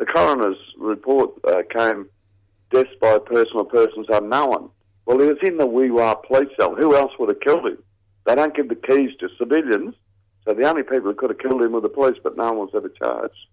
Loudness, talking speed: -19 LUFS, 215 wpm